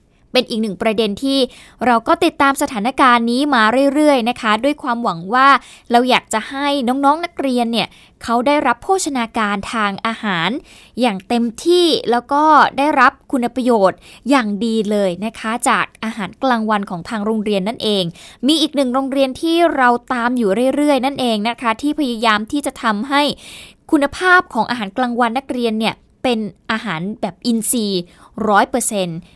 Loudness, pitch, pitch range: -16 LUFS, 240 Hz, 220-275 Hz